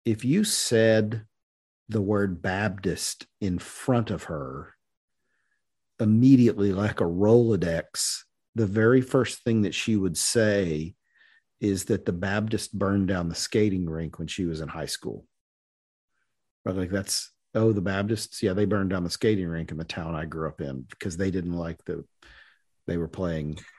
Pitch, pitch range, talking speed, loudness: 100 Hz, 85-110 Hz, 160 wpm, -26 LUFS